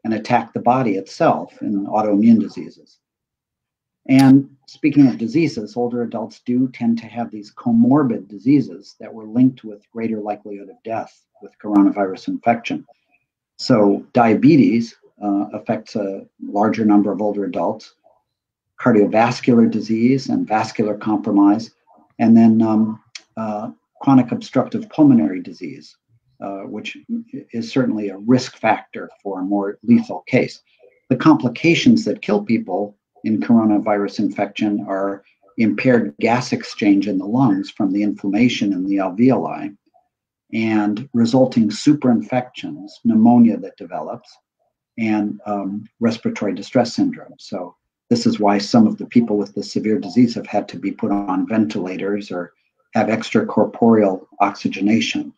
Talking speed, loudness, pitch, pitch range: 130 wpm, -18 LUFS, 115 Hz, 105-150 Hz